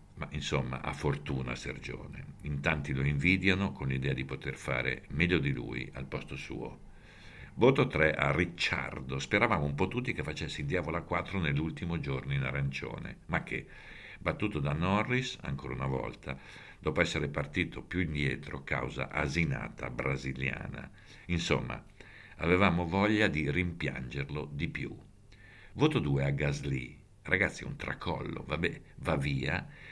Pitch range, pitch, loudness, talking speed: 70-90 Hz, 75 Hz, -32 LUFS, 140 wpm